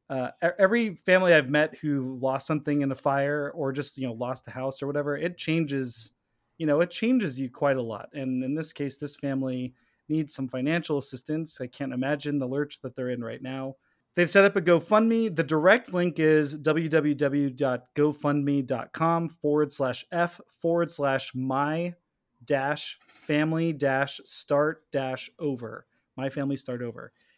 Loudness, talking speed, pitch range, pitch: -27 LUFS, 160 wpm, 130-160 Hz, 145 Hz